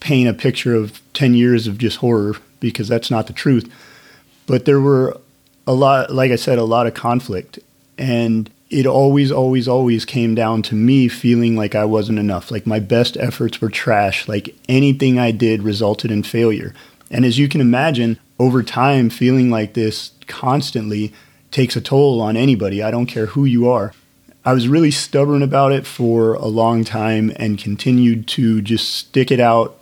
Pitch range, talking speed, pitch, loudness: 110-130 Hz, 185 wpm, 120 Hz, -16 LUFS